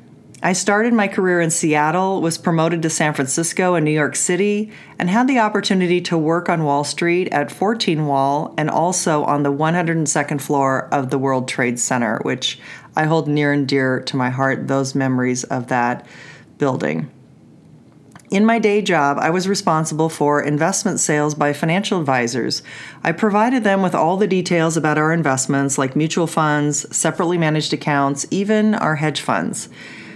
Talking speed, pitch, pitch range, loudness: 170 wpm, 155 Hz, 140-180 Hz, -18 LUFS